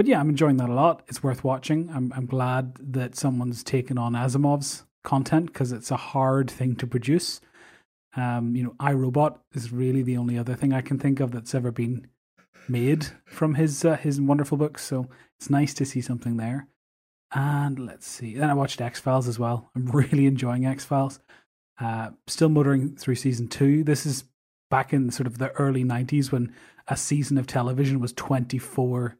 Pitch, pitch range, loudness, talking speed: 130 Hz, 125-140 Hz, -25 LUFS, 195 wpm